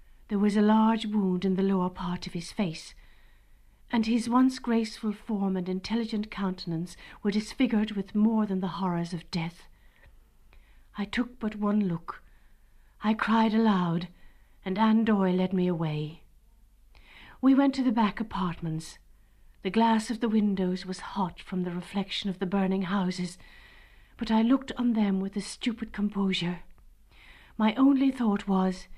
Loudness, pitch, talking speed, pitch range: -28 LUFS, 200 Hz, 155 wpm, 185-225 Hz